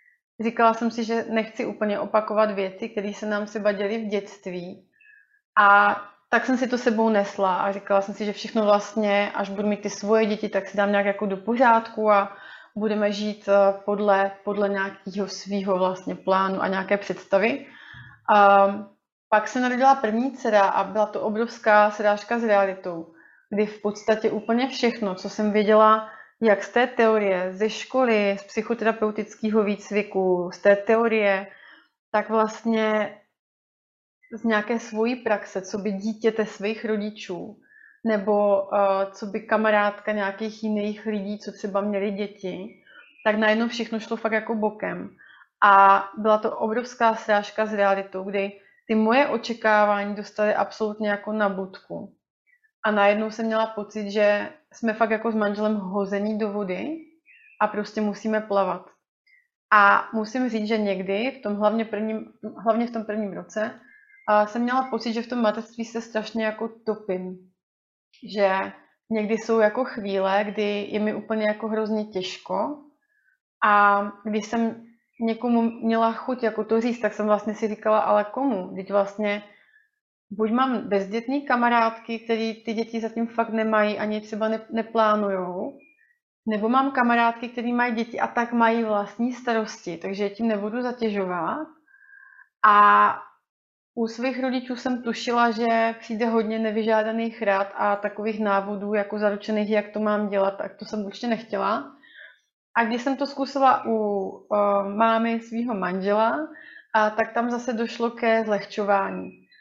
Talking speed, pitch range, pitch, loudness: 150 wpm, 205-230 Hz, 215 Hz, -23 LUFS